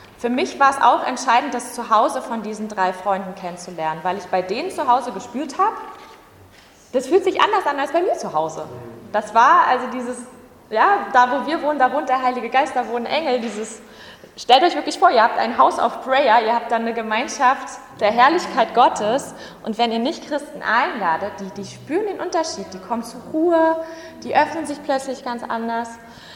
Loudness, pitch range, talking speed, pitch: -19 LUFS, 220-295 Hz, 200 wpm, 250 Hz